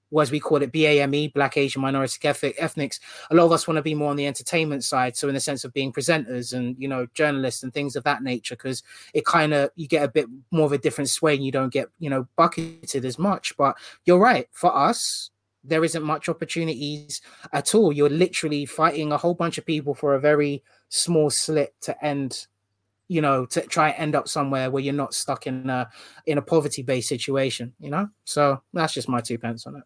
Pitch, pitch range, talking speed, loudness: 145 Hz, 135-155 Hz, 235 wpm, -23 LUFS